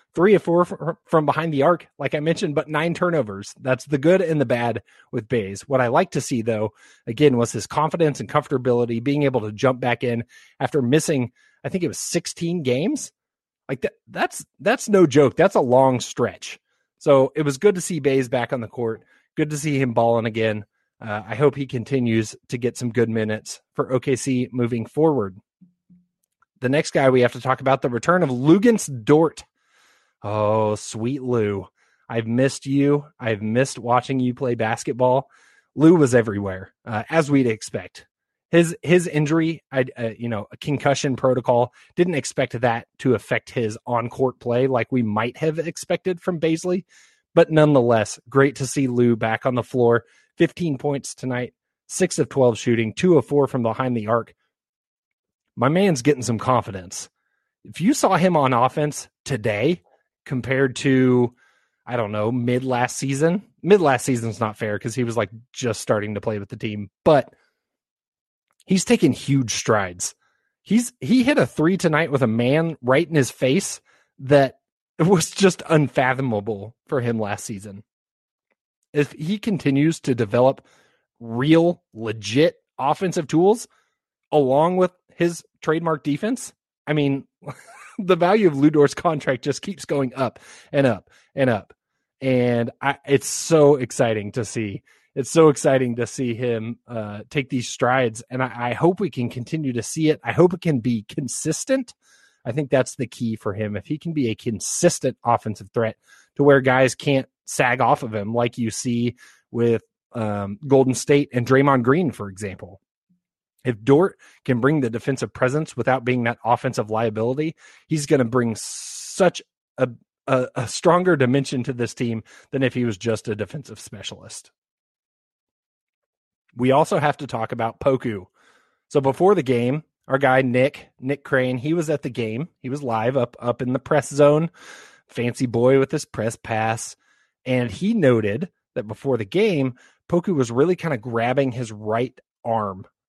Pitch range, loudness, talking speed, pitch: 120-155 Hz, -21 LUFS, 175 wpm, 130 Hz